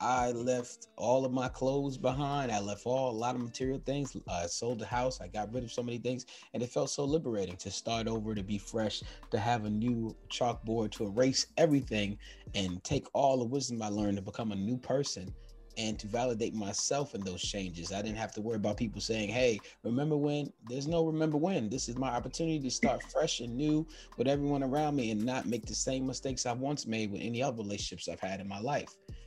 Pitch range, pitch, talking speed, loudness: 105-130 Hz, 120 Hz, 225 wpm, -34 LUFS